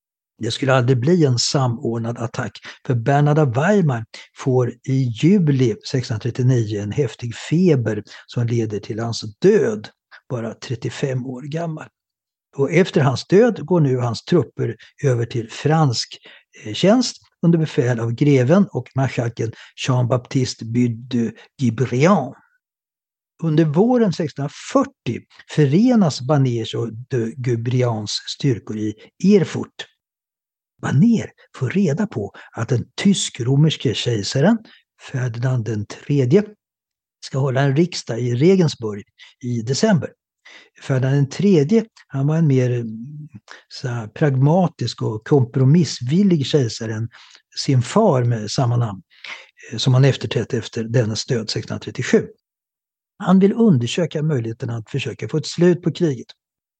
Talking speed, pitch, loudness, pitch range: 115 wpm, 135 Hz, -19 LUFS, 120-160 Hz